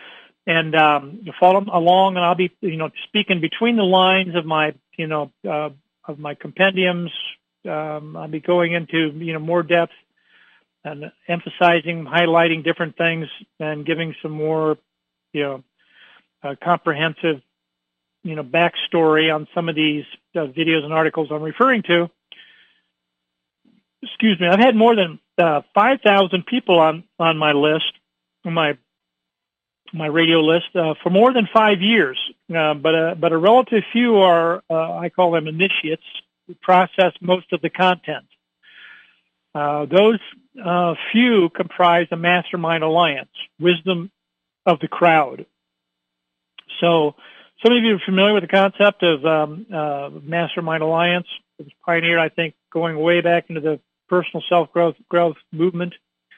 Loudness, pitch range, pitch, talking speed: -18 LUFS, 155-180 Hz, 165 Hz, 150 wpm